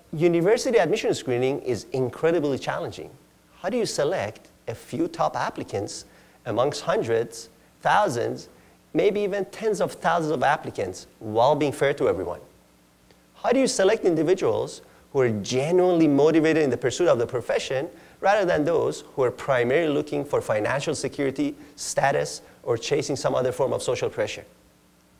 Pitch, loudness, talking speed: 155 Hz, -24 LUFS, 150 wpm